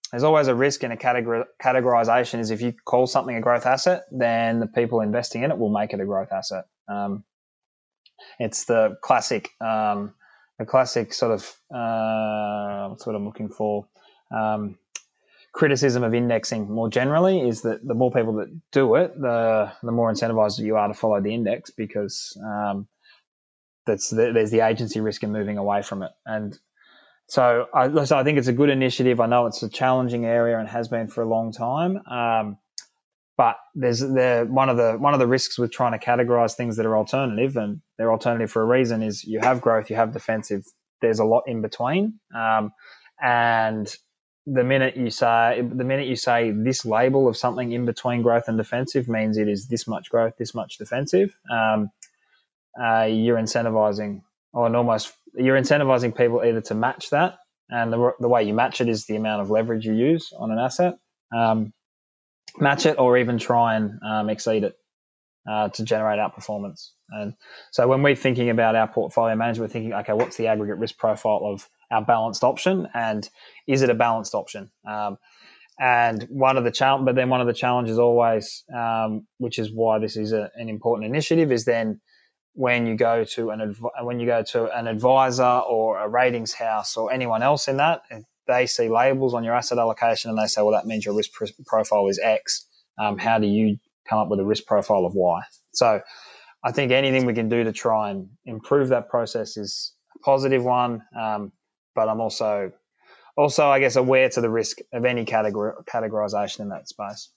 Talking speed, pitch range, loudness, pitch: 195 wpm, 110-125 Hz, -22 LUFS, 115 Hz